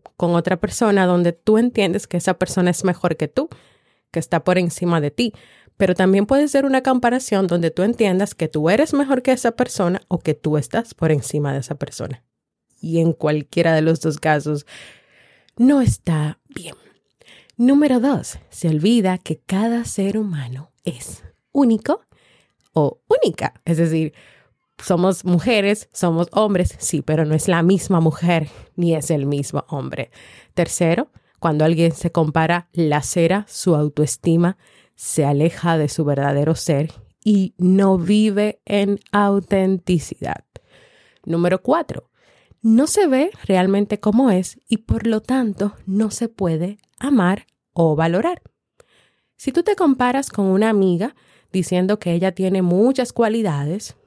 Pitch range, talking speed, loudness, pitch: 165-215 Hz, 150 wpm, -19 LUFS, 185 Hz